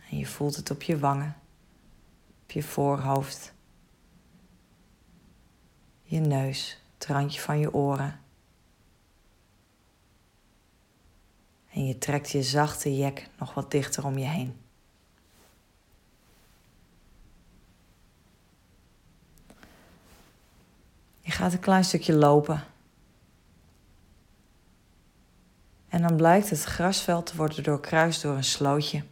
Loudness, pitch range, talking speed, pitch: -27 LUFS, 100-150 Hz, 95 wpm, 140 Hz